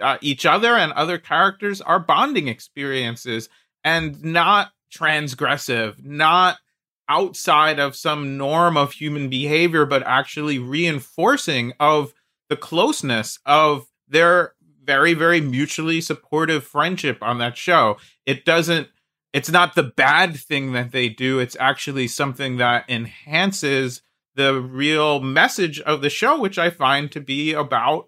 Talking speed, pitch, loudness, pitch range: 135 wpm, 150 Hz, -19 LUFS, 135-165 Hz